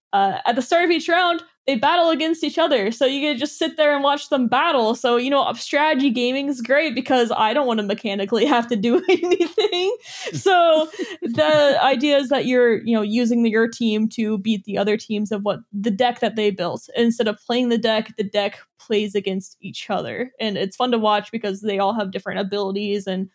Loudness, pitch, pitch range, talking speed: -20 LUFS, 240 Hz, 210-295 Hz, 225 wpm